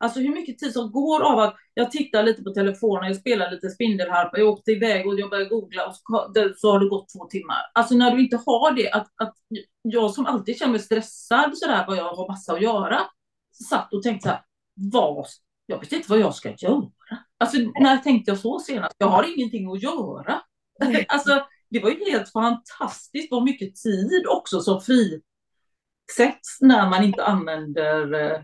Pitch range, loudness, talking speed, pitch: 195-245 Hz, -22 LUFS, 200 wpm, 220 Hz